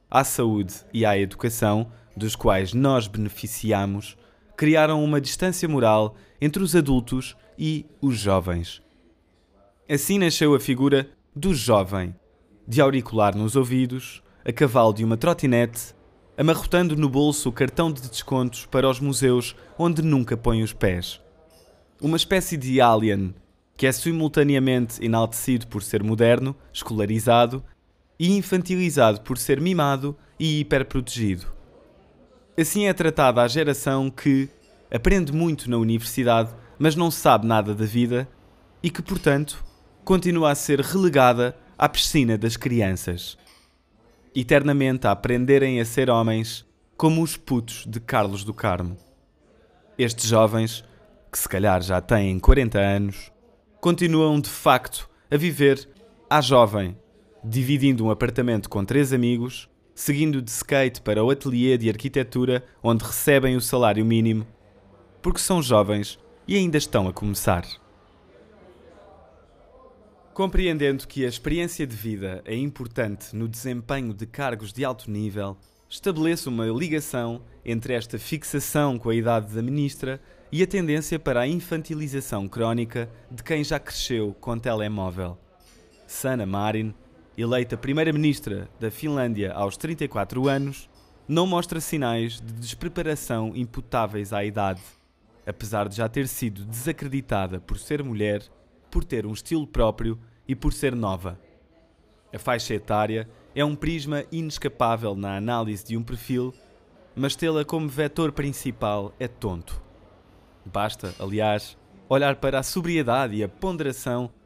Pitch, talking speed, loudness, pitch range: 120 Hz, 135 wpm, -23 LUFS, 110-145 Hz